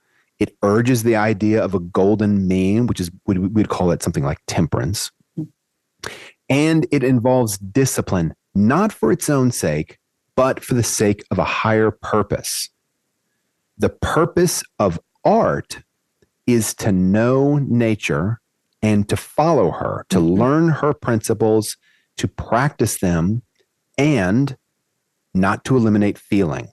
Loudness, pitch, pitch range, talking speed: -18 LUFS, 110 Hz, 100-130 Hz, 130 wpm